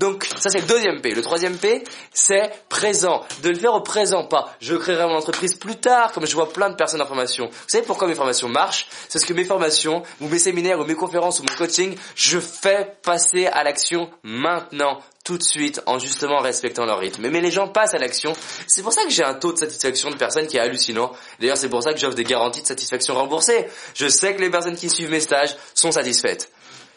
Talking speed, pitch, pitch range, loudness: 240 wpm, 170 Hz, 150-195 Hz, -19 LUFS